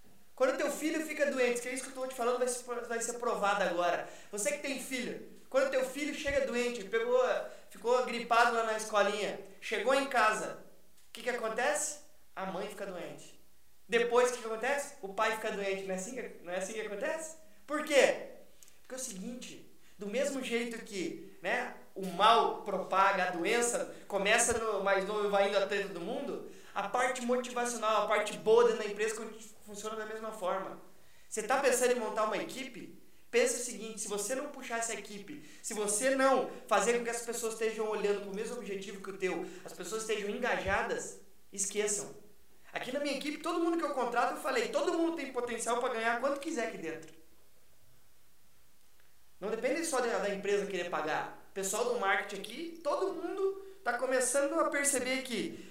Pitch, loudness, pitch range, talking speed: 230 Hz, -33 LUFS, 205-265 Hz, 190 wpm